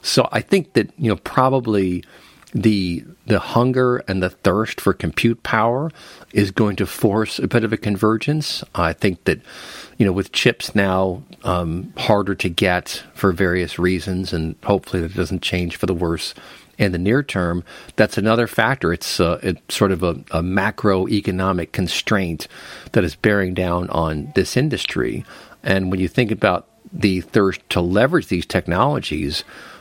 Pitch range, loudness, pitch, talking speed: 90-110 Hz, -20 LUFS, 95 Hz, 165 wpm